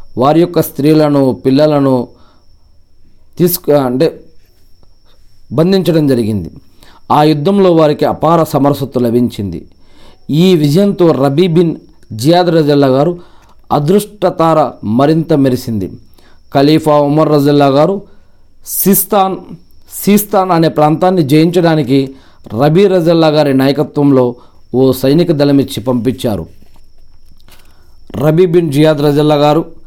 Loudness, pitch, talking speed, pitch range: -10 LUFS, 145 Hz, 90 wpm, 120-165 Hz